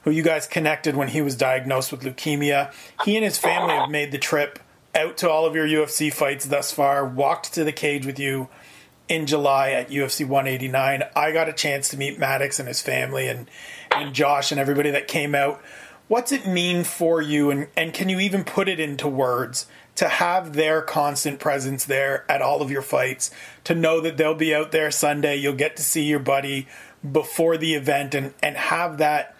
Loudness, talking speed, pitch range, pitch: -22 LUFS, 210 wpm, 140-160 Hz, 150 Hz